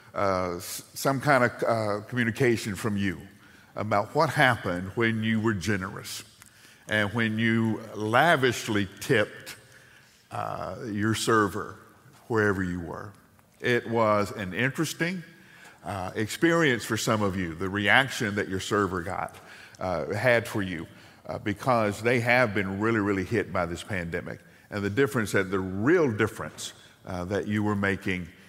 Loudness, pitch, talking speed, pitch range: -26 LUFS, 105 Hz, 145 wpm, 95-120 Hz